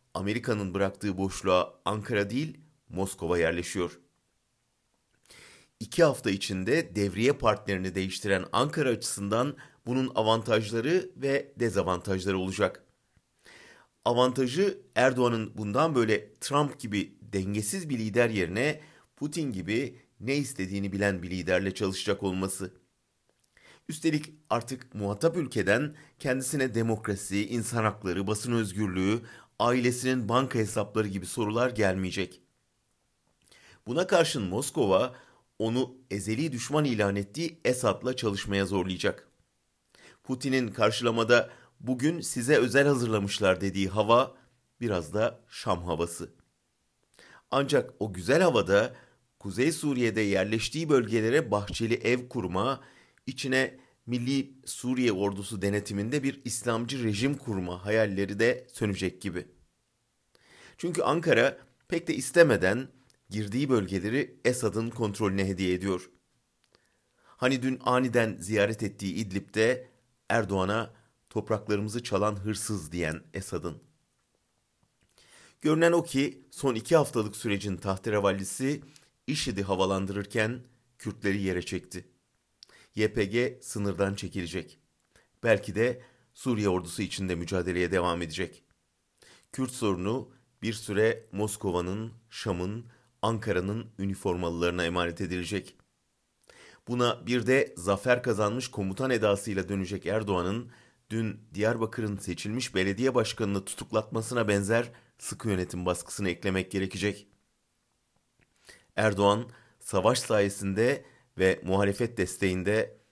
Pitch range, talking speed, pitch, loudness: 95-125 Hz, 100 wpm, 110 Hz, -29 LUFS